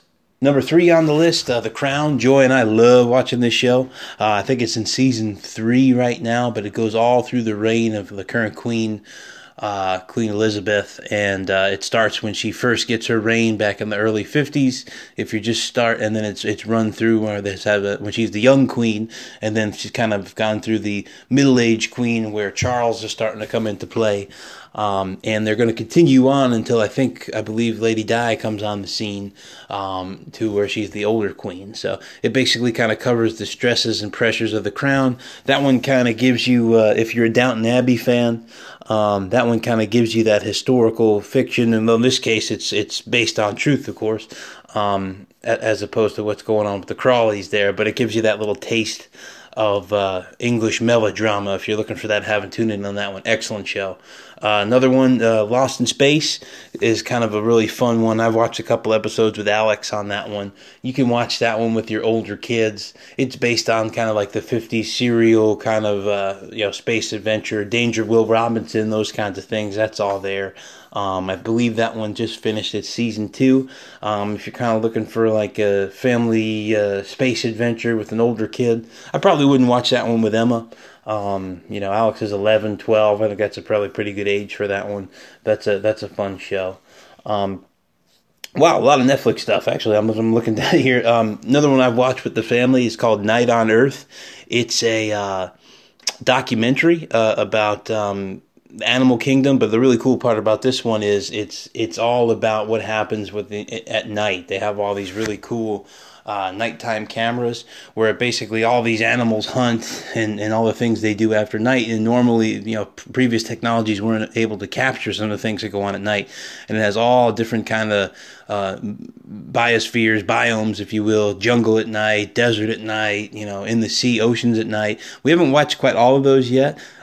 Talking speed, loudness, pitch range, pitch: 210 wpm, -18 LUFS, 105-120 Hz, 110 Hz